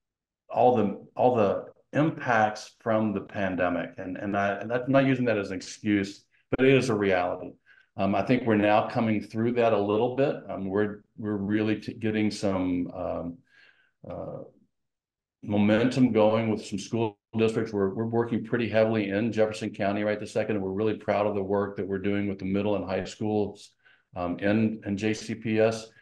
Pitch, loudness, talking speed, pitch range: 105 Hz, -27 LUFS, 190 wpm, 100-110 Hz